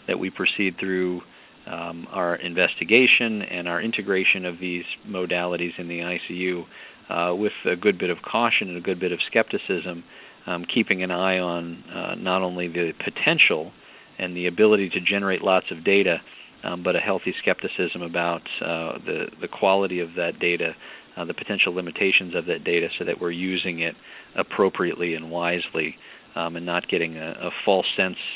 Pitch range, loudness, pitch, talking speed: 85-95 Hz, -23 LUFS, 90 Hz, 175 wpm